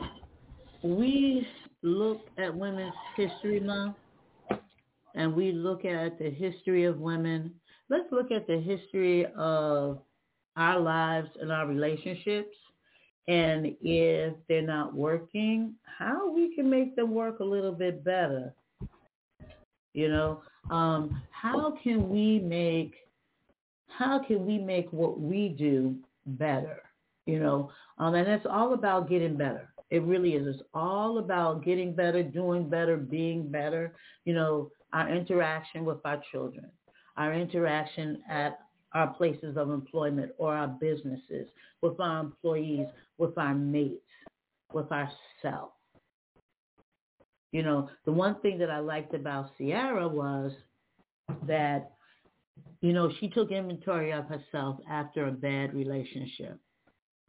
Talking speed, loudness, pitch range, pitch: 130 wpm, -31 LUFS, 150-190 Hz, 165 Hz